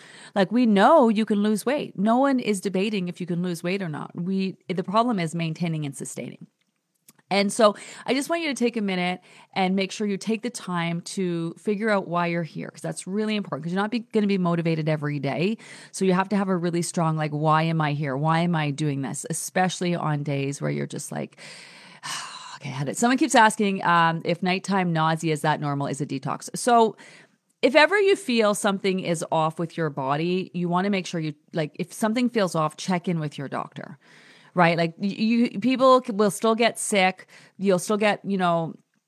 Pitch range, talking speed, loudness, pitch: 165-210 Hz, 225 wpm, -24 LUFS, 185 Hz